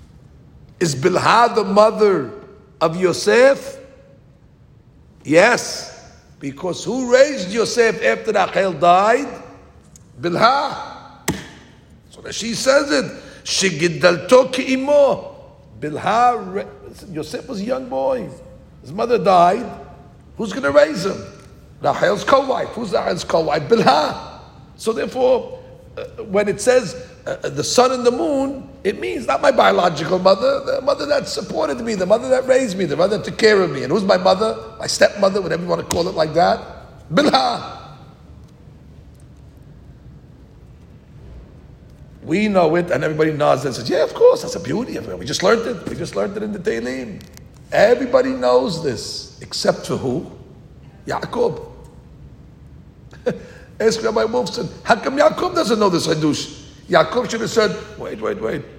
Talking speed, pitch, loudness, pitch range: 150 wpm, 225 Hz, -18 LUFS, 180-265 Hz